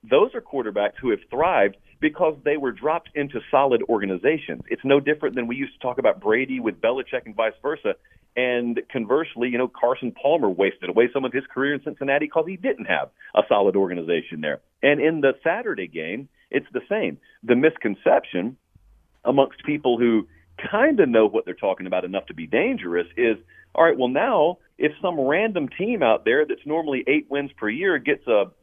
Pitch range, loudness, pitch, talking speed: 120-165 Hz, -22 LUFS, 140 Hz, 195 wpm